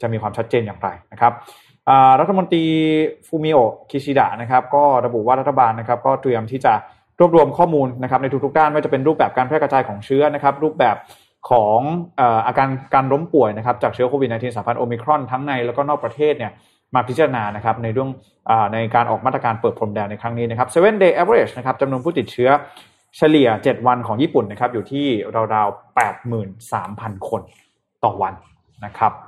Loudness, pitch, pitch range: -18 LUFS, 130 Hz, 115-145 Hz